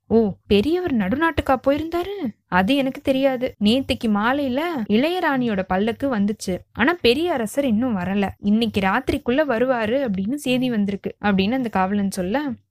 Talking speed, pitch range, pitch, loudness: 125 wpm, 205-275 Hz, 245 Hz, -21 LUFS